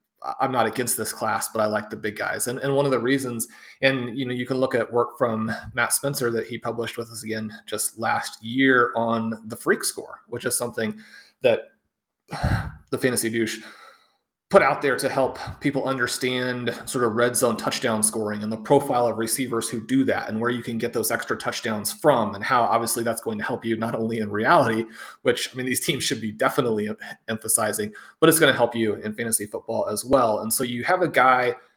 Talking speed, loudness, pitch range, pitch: 220 wpm, -23 LUFS, 110-130 Hz, 120 Hz